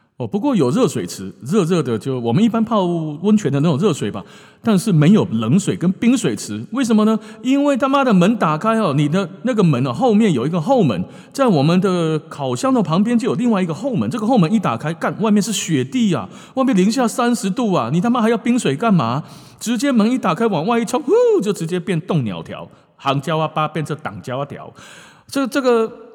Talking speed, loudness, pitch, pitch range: 320 characters per minute, -17 LUFS, 205 Hz, 160-235 Hz